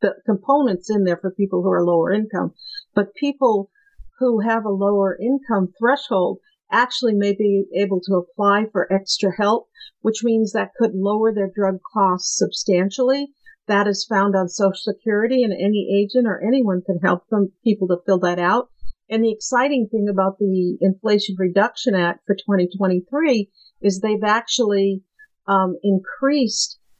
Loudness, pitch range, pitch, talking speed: -20 LUFS, 190-230 Hz, 205 Hz, 160 wpm